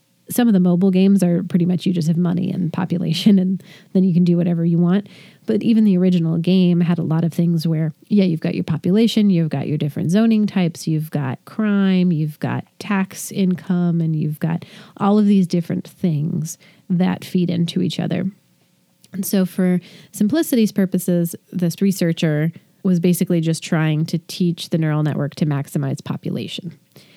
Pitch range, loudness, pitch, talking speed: 170-190 Hz, -19 LUFS, 180 Hz, 185 wpm